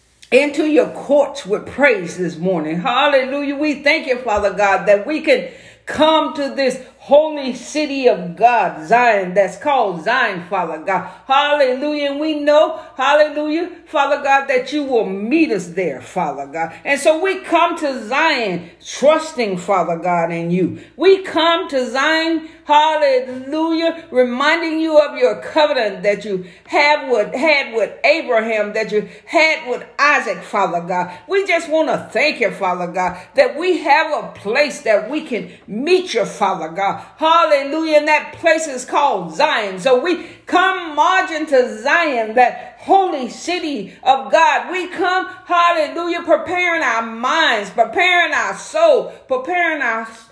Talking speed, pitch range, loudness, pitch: 155 wpm, 225-320 Hz, -16 LUFS, 290 Hz